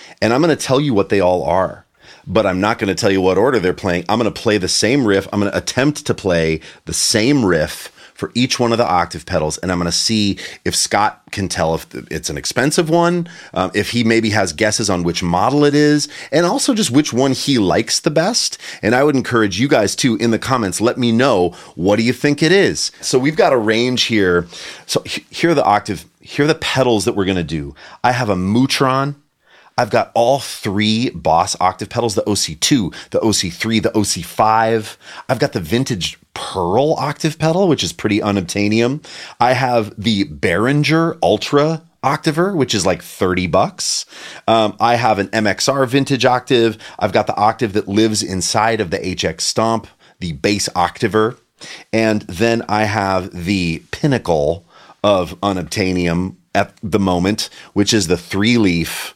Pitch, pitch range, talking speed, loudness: 110 Hz, 95-125 Hz, 195 wpm, -16 LUFS